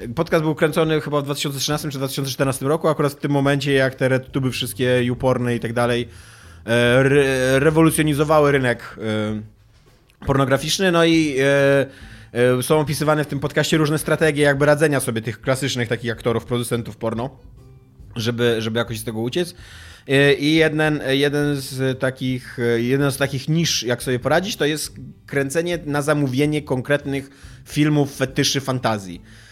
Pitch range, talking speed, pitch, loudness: 120-150 Hz, 150 wpm, 135 Hz, -19 LUFS